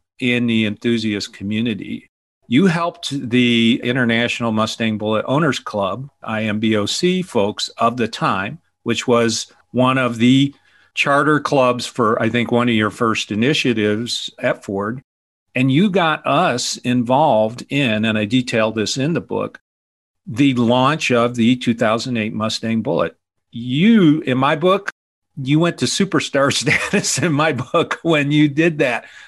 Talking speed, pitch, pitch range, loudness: 145 wpm, 125 Hz, 110-145 Hz, -17 LUFS